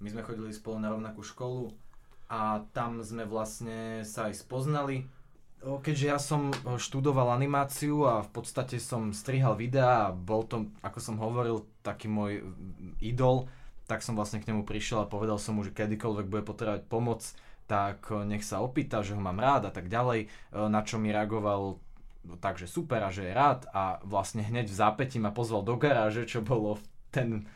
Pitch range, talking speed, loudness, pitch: 105-125 Hz, 180 wpm, -32 LUFS, 110 Hz